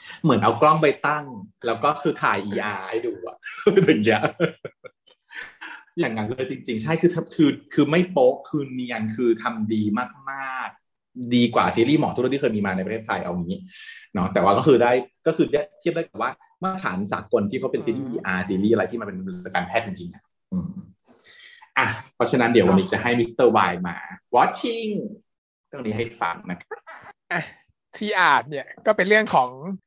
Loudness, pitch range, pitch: -22 LUFS, 120-200 Hz, 160 Hz